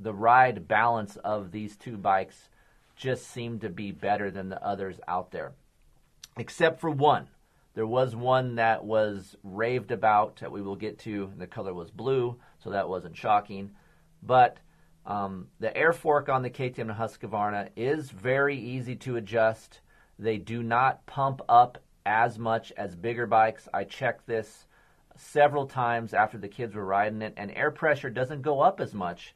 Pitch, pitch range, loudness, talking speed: 115 Hz, 105-130 Hz, -28 LUFS, 170 wpm